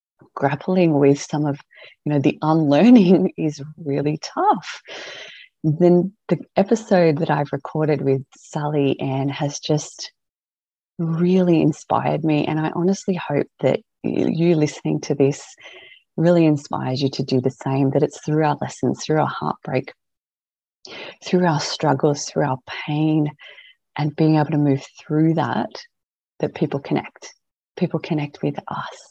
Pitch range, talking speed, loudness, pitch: 140-165 Hz, 145 wpm, -20 LUFS, 150 Hz